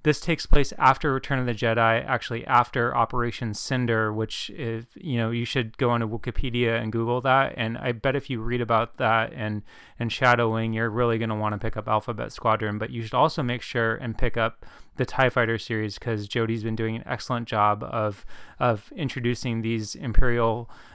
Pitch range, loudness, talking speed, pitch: 115-125 Hz, -25 LUFS, 205 wpm, 115 Hz